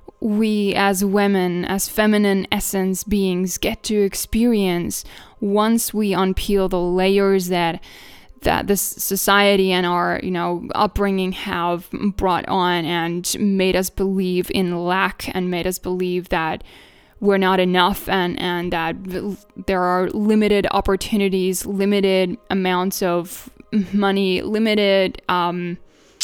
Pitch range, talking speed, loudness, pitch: 180-200 Hz, 125 wpm, -19 LUFS, 190 Hz